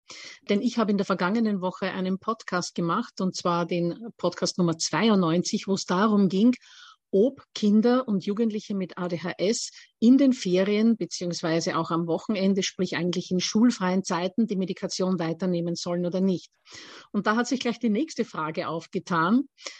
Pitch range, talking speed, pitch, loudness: 175-220 Hz, 160 wpm, 190 Hz, -25 LUFS